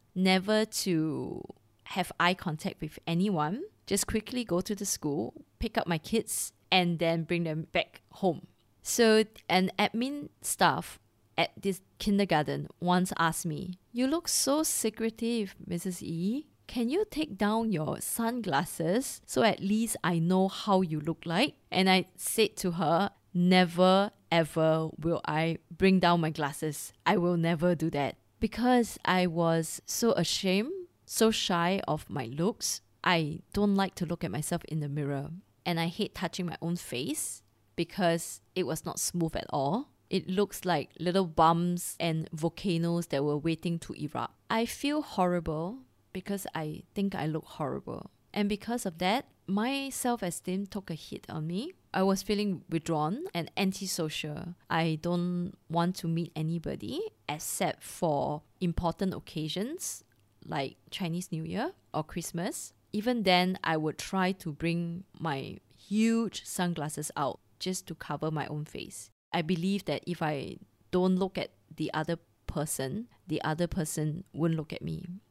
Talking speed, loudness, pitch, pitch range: 155 wpm, -31 LUFS, 175 Hz, 165-200 Hz